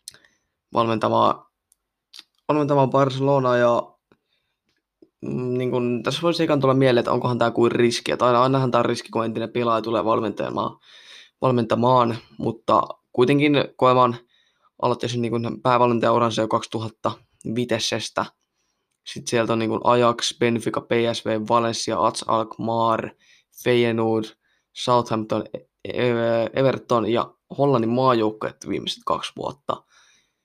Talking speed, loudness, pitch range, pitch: 105 wpm, -22 LUFS, 115-125 Hz, 120 Hz